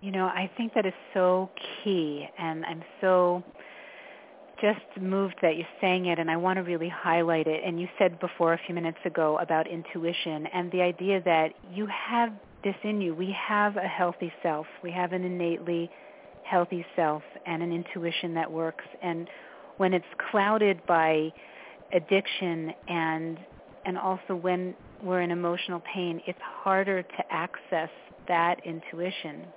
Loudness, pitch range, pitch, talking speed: -29 LUFS, 165-190 Hz, 180 Hz, 160 wpm